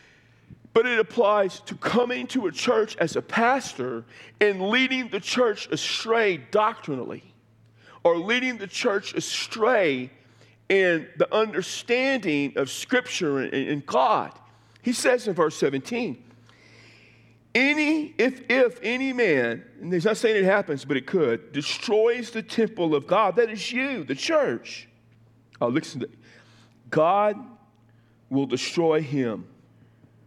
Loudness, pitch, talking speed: -24 LUFS, 170 Hz, 130 wpm